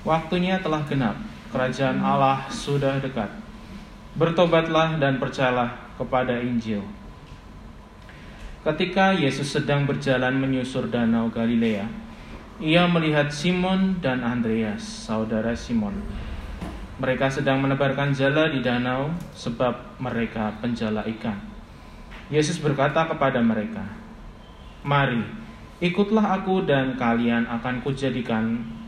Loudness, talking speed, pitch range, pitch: -24 LUFS, 100 wpm, 115-155 Hz, 135 Hz